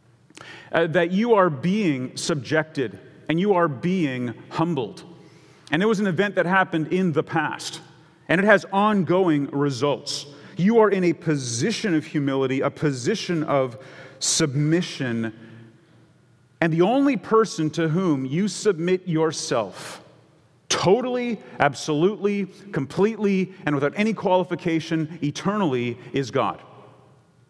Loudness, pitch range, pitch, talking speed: -23 LUFS, 145-185 Hz, 165 Hz, 120 wpm